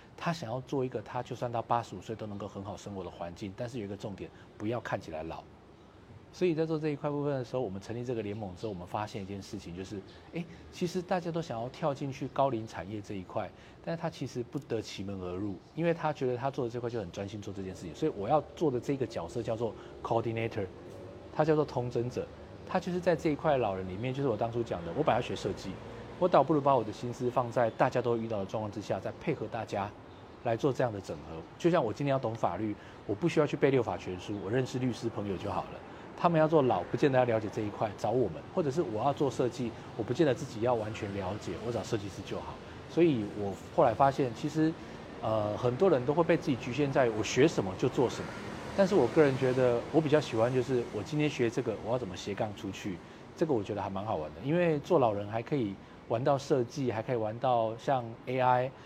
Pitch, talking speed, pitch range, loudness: 120 Hz, 370 characters per minute, 105-140 Hz, -32 LUFS